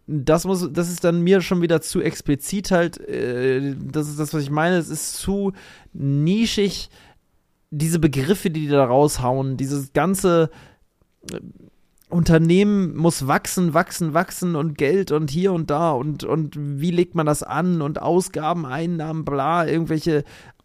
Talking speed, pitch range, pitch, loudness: 150 wpm, 145-175 Hz, 160 Hz, -21 LUFS